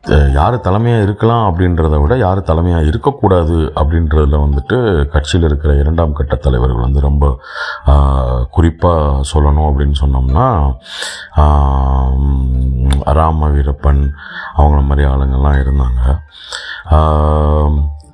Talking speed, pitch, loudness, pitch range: 90 wpm, 75 Hz, -13 LUFS, 70-80 Hz